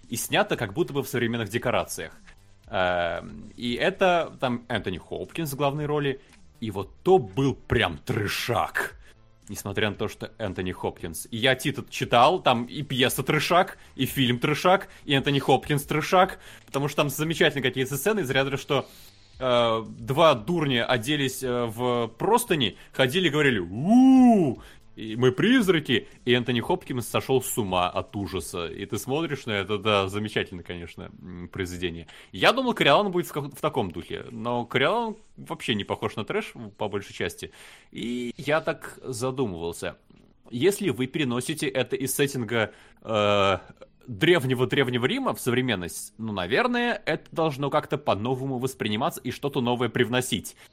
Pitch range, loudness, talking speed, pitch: 110-150 Hz, -25 LUFS, 155 wpm, 130 Hz